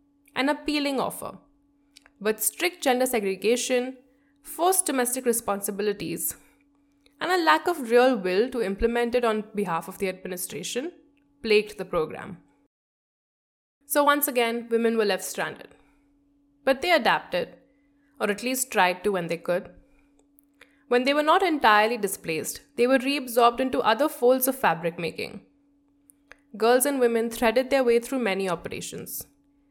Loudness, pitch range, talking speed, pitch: -24 LUFS, 215-285 Hz, 140 wpm, 255 Hz